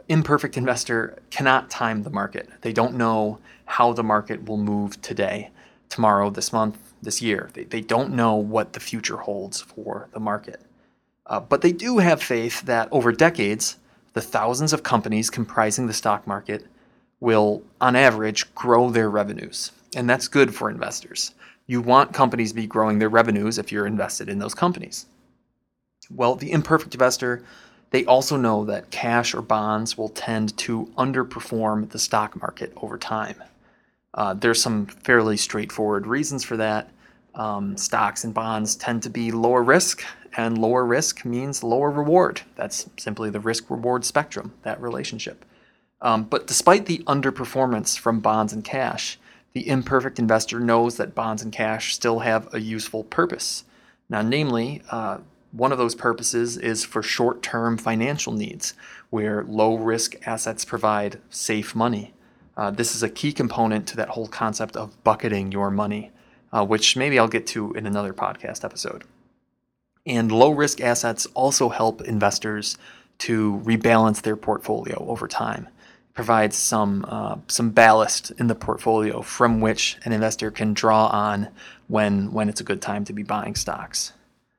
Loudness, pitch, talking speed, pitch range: -22 LUFS, 115 Hz, 160 wpm, 110-120 Hz